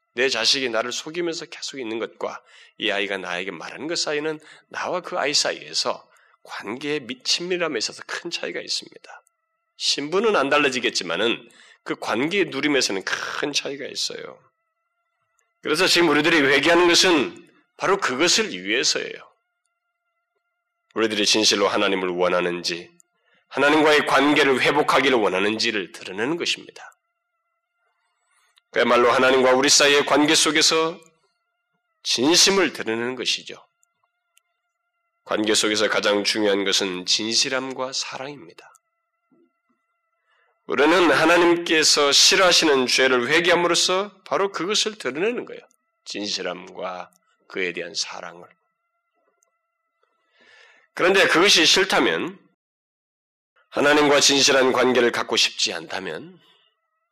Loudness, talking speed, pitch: -19 LUFS, 285 characters per minute, 180 Hz